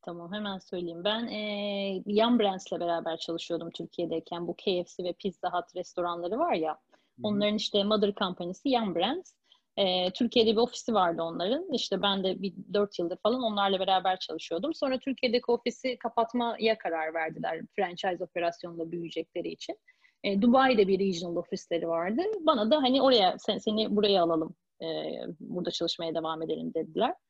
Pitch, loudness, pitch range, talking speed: 195 Hz, -29 LUFS, 175-230 Hz, 155 wpm